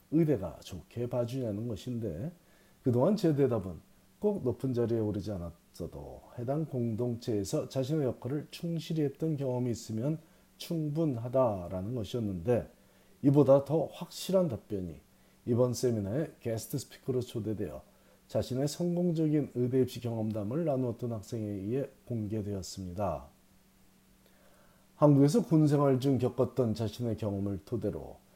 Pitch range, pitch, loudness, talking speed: 110-145 Hz, 125 Hz, -32 LUFS, 305 characters per minute